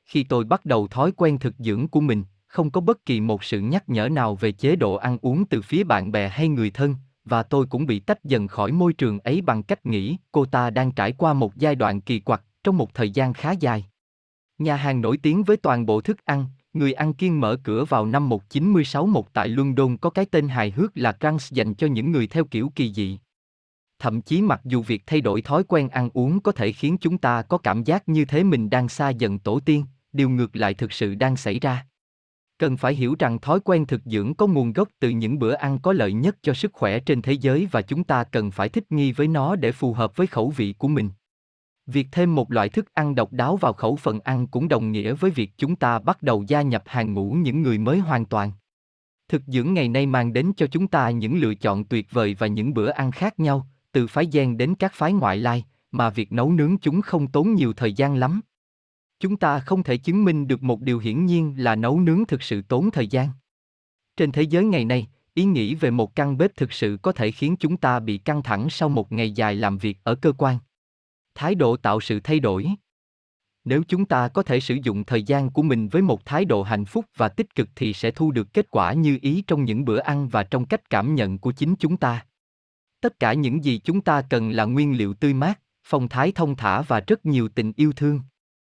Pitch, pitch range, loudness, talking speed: 130 Hz, 110-155 Hz, -22 LUFS, 245 wpm